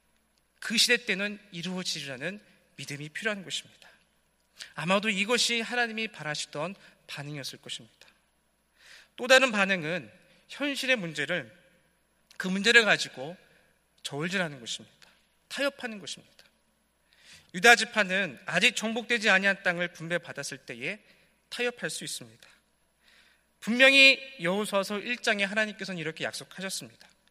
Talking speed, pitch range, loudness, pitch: 295 characters per minute, 160-225 Hz, -26 LUFS, 195 Hz